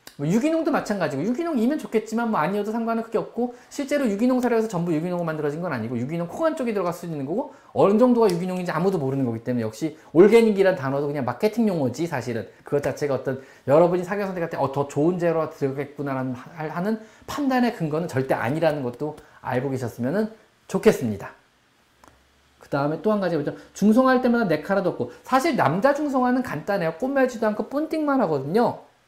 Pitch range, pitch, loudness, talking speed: 145-230 Hz, 180 Hz, -23 LUFS, 440 characters per minute